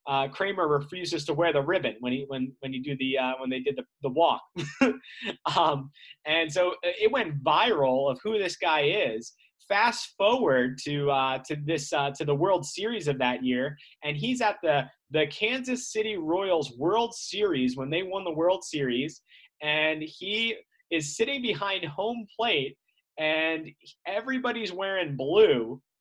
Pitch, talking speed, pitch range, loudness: 160 Hz, 170 wpm, 140-210 Hz, -27 LUFS